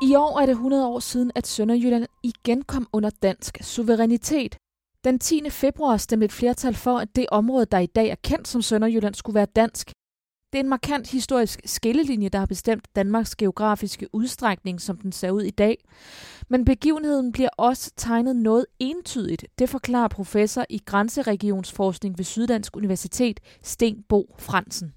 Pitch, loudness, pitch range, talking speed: 230 Hz, -23 LUFS, 205-255 Hz, 165 wpm